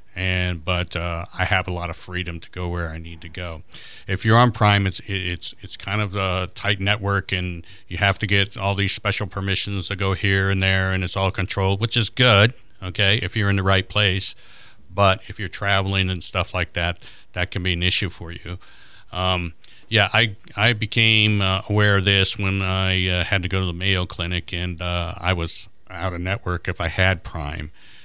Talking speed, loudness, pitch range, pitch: 215 wpm, -21 LUFS, 90-100 Hz, 95 Hz